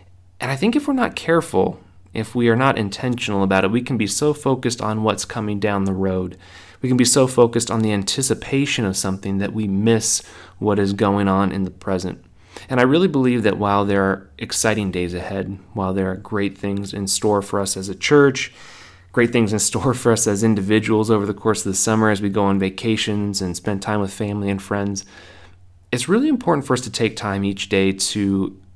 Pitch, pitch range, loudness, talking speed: 105 Hz, 95-115 Hz, -19 LUFS, 220 wpm